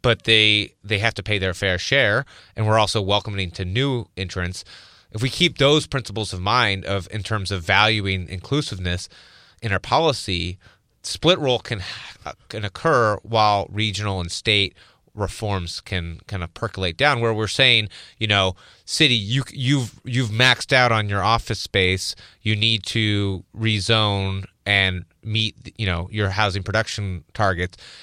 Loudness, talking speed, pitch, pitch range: -20 LUFS, 160 wpm, 105 Hz, 95-115 Hz